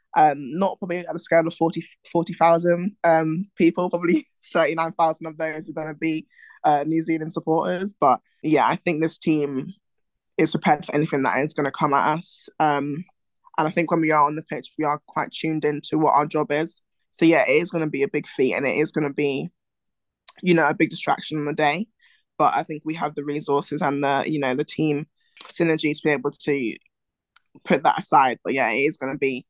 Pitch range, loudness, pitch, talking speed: 150-170 Hz, -22 LUFS, 155 Hz, 225 wpm